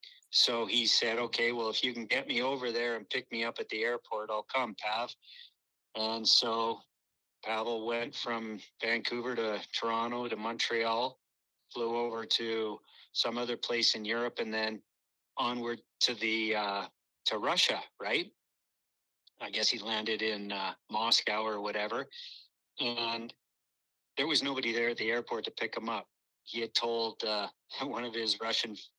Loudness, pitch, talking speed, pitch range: -32 LUFS, 115 Hz, 160 wpm, 110-120 Hz